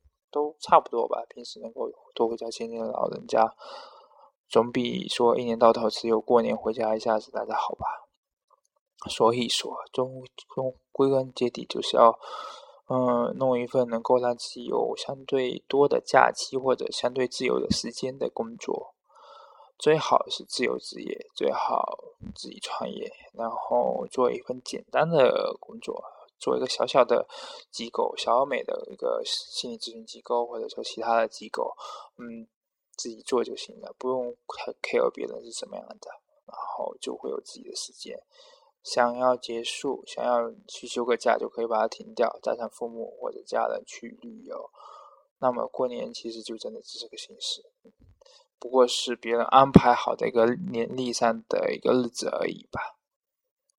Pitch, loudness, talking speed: 135 Hz, -27 LUFS, 245 characters per minute